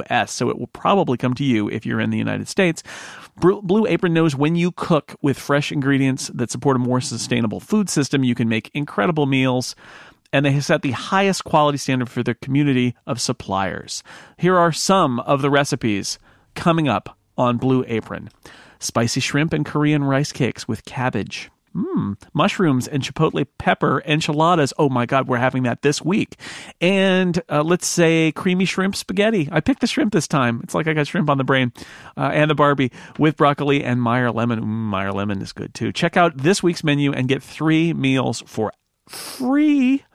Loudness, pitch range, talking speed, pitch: -19 LUFS, 125-165 Hz, 190 wpm, 140 Hz